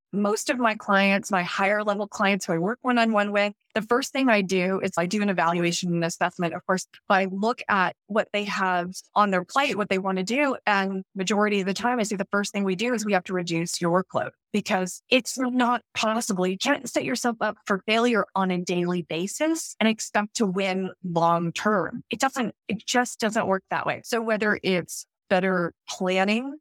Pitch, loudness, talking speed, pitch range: 205 Hz, -25 LUFS, 210 wpm, 185-225 Hz